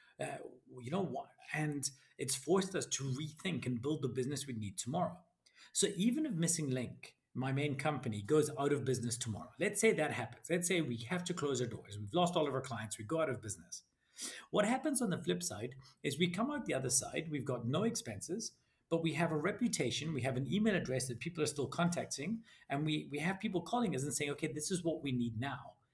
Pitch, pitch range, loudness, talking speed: 145 Hz, 130-175 Hz, -37 LUFS, 235 wpm